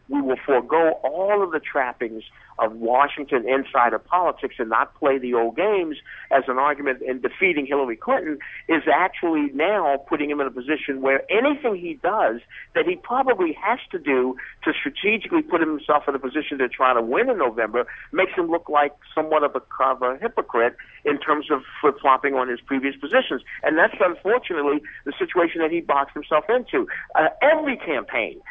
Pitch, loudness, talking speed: 155 Hz, -22 LUFS, 180 wpm